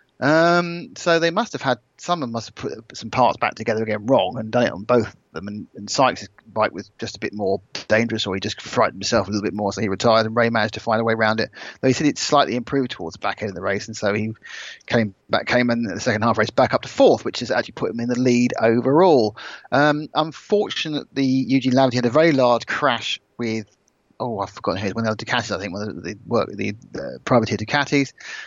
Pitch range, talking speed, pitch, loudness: 110-135 Hz, 255 wpm, 120 Hz, -21 LUFS